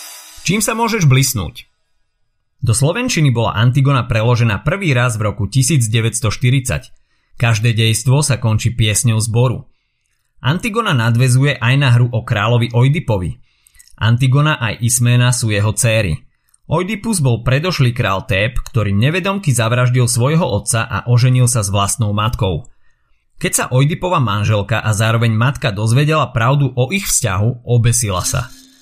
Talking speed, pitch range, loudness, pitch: 135 wpm, 110-135 Hz, -15 LUFS, 120 Hz